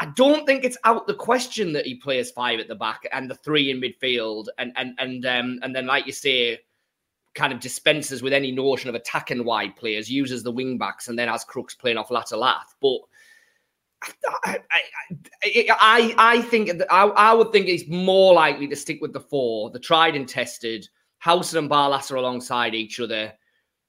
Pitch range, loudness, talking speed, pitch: 125-210 Hz, -21 LUFS, 195 wpm, 140 Hz